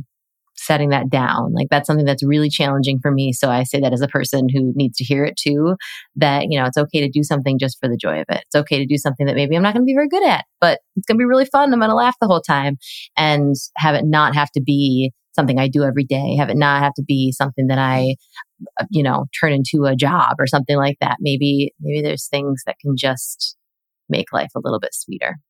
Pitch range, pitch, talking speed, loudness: 135-150 Hz, 140 Hz, 260 wpm, -17 LUFS